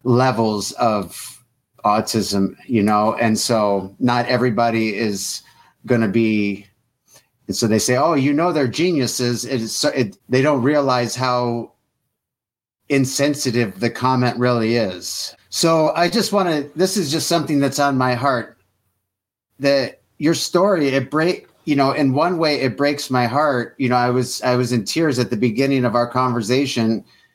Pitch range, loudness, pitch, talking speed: 115-140 Hz, -19 LUFS, 125 Hz, 165 wpm